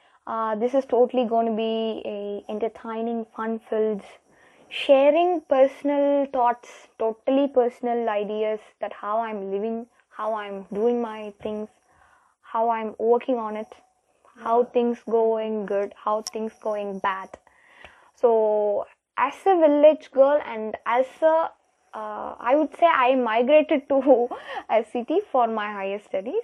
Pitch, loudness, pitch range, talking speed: 230 Hz, -23 LUFS, 215-270 Hz, 135 wpm